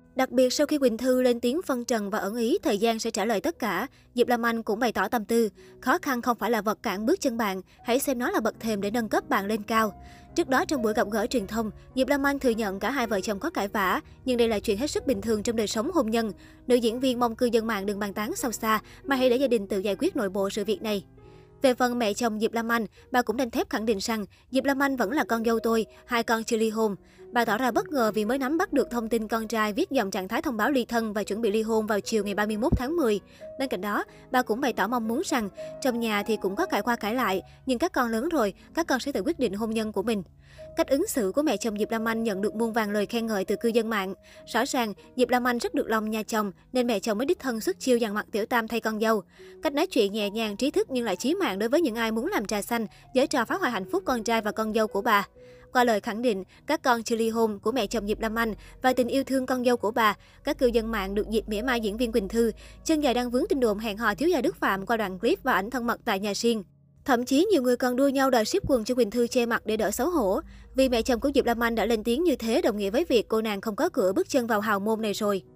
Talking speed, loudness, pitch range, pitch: 305 wpm, -26 LUFS, 215-260 Hz, 235 Hz